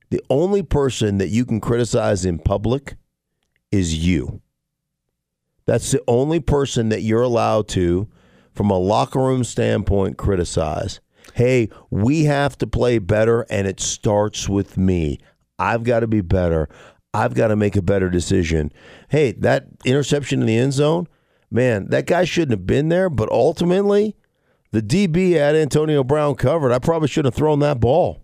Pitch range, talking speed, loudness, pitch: 100-145 Hz, 165 wpm, -19 LUFS, 120 Hz